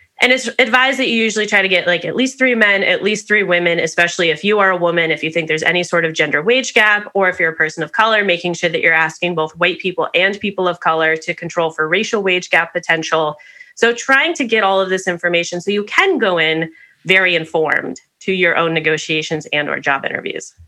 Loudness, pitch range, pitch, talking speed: -15 LUFS, 165-210 Hz, 180 Hz, 240 wpm